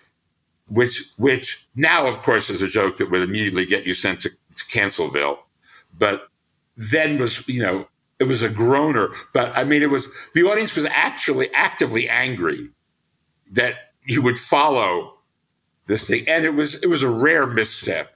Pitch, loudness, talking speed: 120 Hz, -20 LUFS, 170 wpm